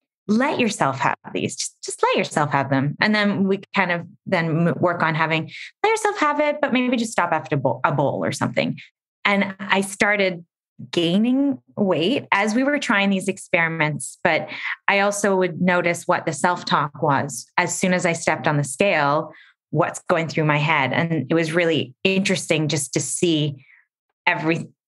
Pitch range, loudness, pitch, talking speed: 160-205 Hz, -21 LUFS, 180 Hz, 185 wpm